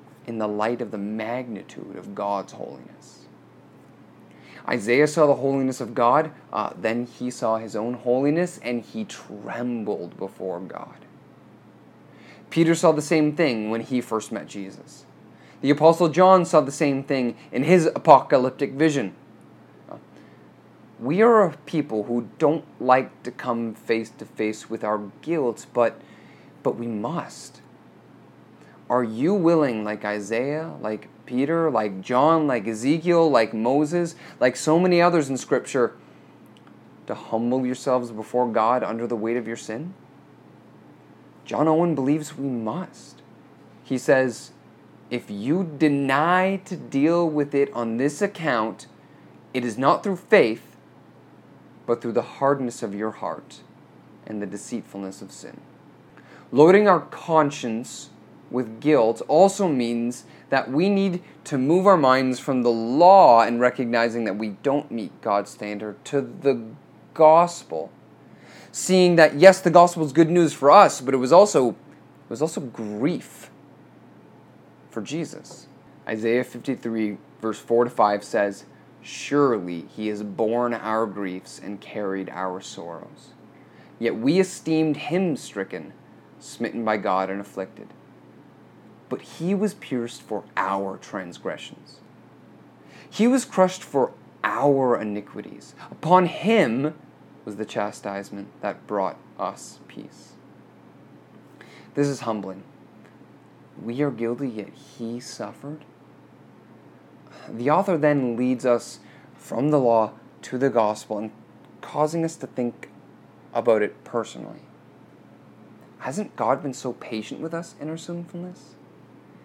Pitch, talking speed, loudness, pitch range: 125 Hz, 135 wpm, -22 LUFS, 110-155 Hz